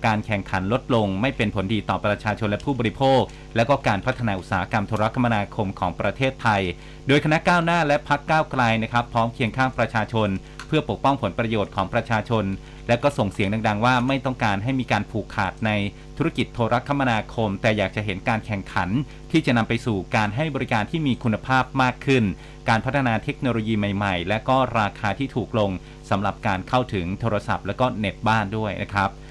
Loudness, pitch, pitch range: -23 LUFS, 115 Hz, 105-130 Hz